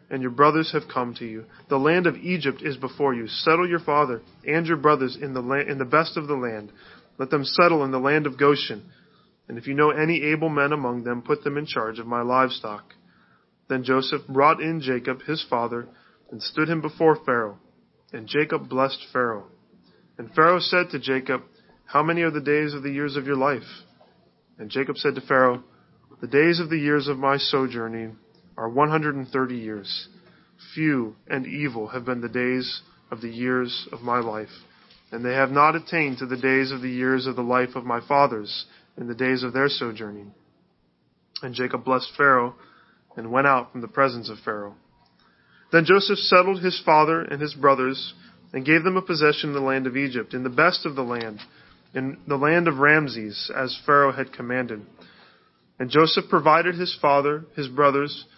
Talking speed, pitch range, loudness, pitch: 195 wpm, 125-150 Hz, -23 LUFS, 135 Hz